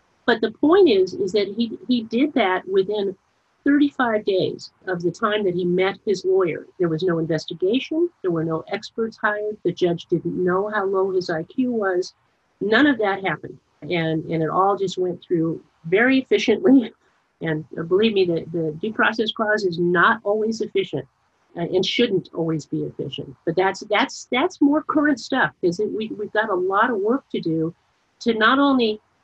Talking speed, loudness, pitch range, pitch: 180 wpm, -21 LUFS, 175-230 Hz, 200 Hz